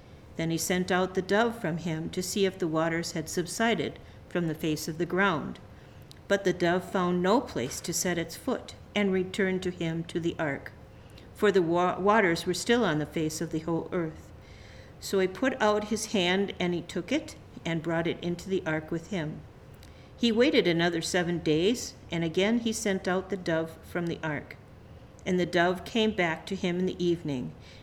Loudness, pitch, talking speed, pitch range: -29 LUFS, 175 Hz, 200 wpm, 160-190 Hz